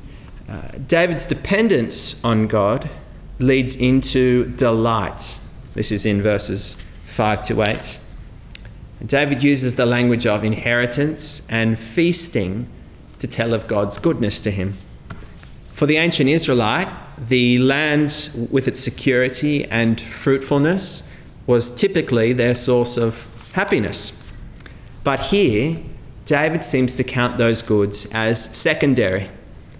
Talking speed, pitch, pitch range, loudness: 115 wpm, 120 Hz, 110-140 Hz, -18 LUFS